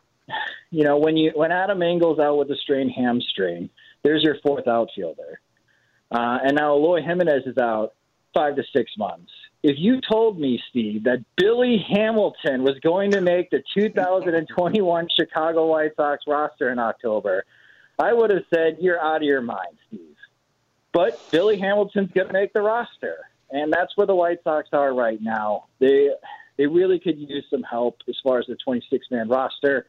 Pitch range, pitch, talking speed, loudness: 140-210 Hz, 165 Hz, 175 wpm, -21 LUFS